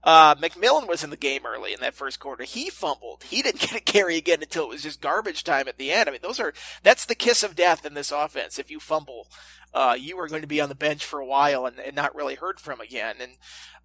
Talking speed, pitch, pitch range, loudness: 270 wpm, 155 Hz, 150-175 Hz, -23 LUFS